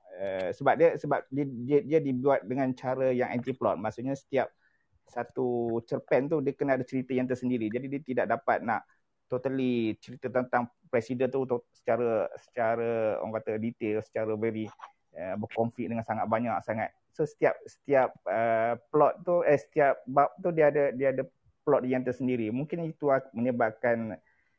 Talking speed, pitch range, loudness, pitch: 165 wpm, 115-135 Hz, -29 LUFS, 125 Hz